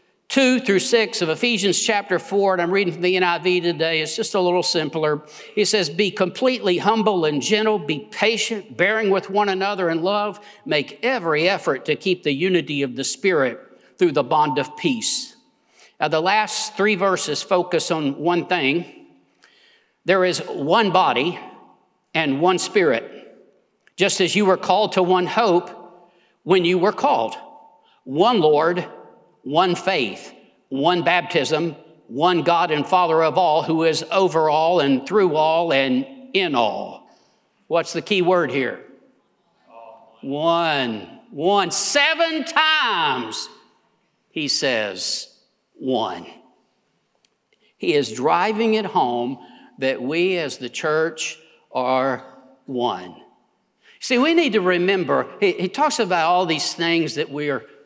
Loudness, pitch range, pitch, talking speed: -20 LUFS, 155-210 Hz, 180 Hz, 145 wpm